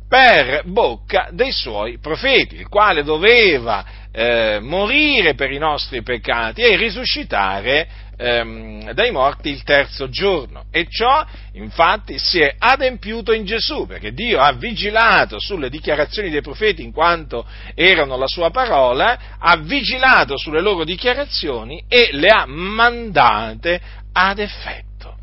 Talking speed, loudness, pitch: 130 wpm, -16 LUFS, 180 Hz